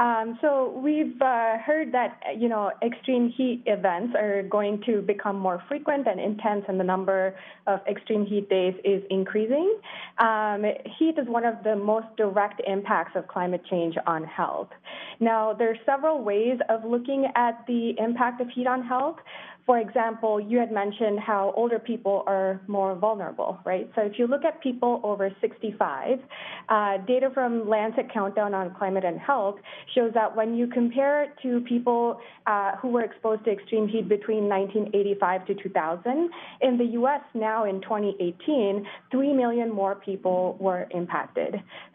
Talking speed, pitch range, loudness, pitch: 165 wpm, 200-245 Hz, -26 LUFS, 220 Hz